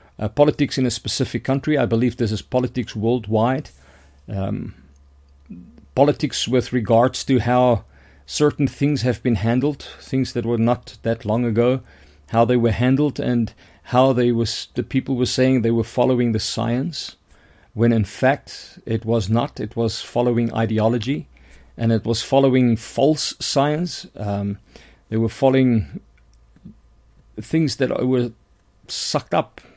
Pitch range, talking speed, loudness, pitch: 110-130 Hz, 145 wpm, -20 LUFS, 120 Hz